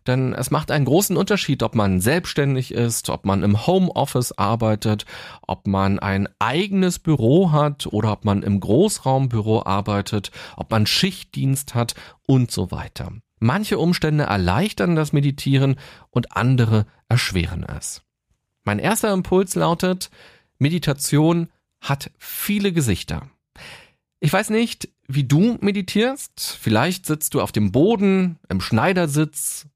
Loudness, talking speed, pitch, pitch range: -20 LUFS, 130 wpm, 135 Hz, 105-175 Hz